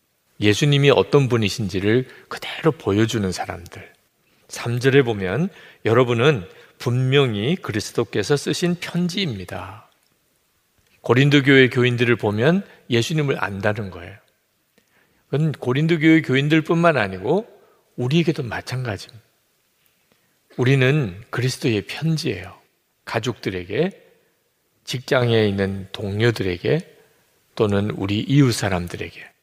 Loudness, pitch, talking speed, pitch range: -20 LUFS, 120 Hz, 265 characters per minute, 105-145 Hz